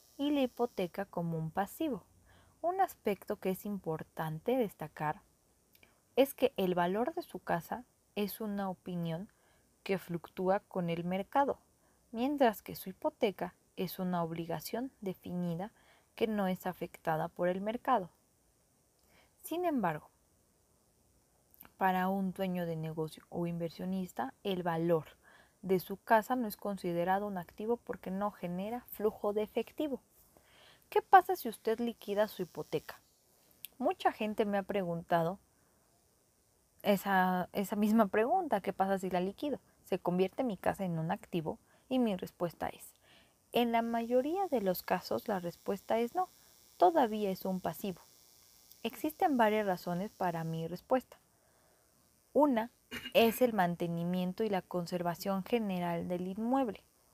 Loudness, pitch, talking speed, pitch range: -35 LUFS, 195 Hz, 135 wpm, 180-230 Hz